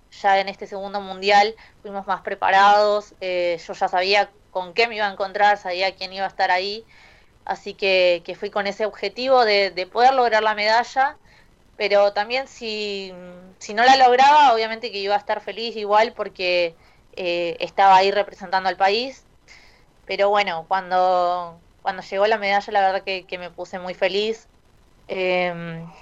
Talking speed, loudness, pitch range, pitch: 170 wpm, -20 LUFS, 185-210 Hz, 200 Hz